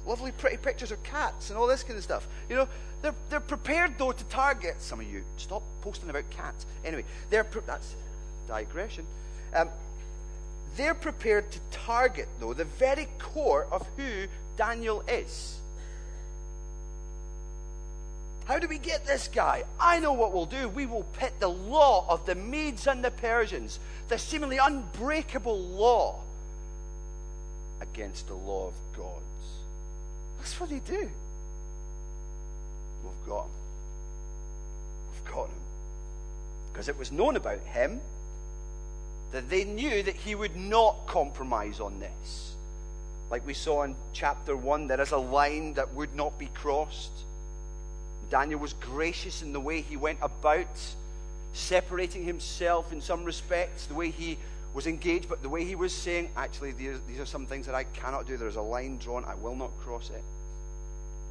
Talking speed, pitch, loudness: 155 wpm, 135 Hz, -31 LUFS